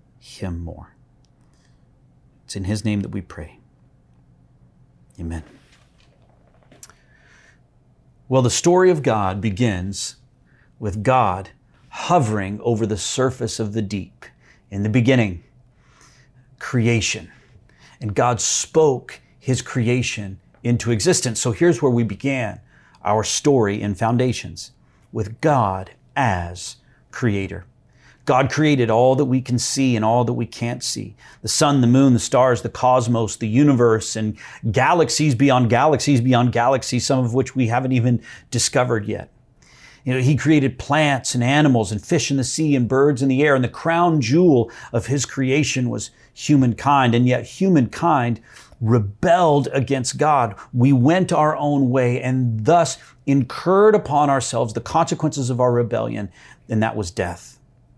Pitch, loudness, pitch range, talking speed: 125 Hz, -19 LUFS, 110-135 Hz, 140 wpm